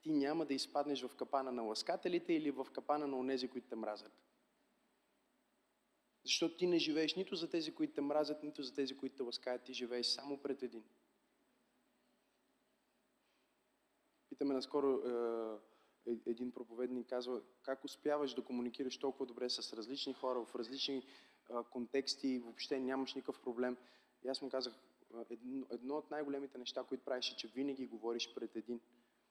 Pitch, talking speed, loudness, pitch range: 130 Hz, 160 wpm, -42 LUFS, 125-140 Hz